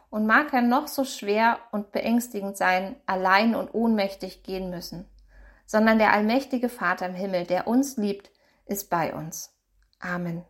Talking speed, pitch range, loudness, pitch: 155 wpm, 185-240 Hz, -25 LUFS, 205 Hz